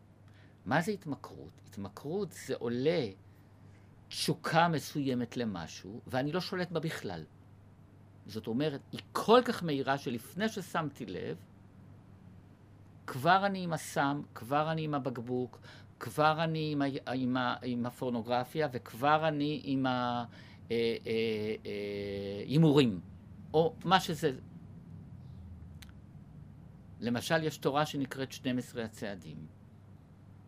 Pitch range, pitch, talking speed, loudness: 100-150 Hz, 120 Hz, 110 wpm, -33 LUFS